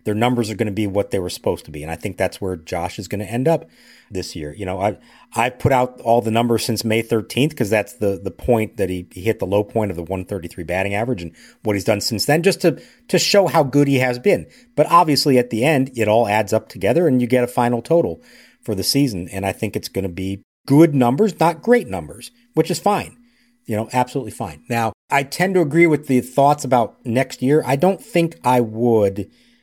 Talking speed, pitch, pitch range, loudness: 250 wpm, 120 Hz, 105-145 Hz, -19 LUFS